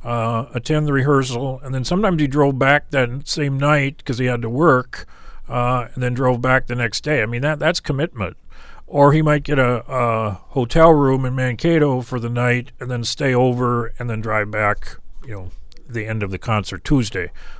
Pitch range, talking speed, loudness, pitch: 120-145 Hz, 205 wpm, -19 LUFS, 125 Hz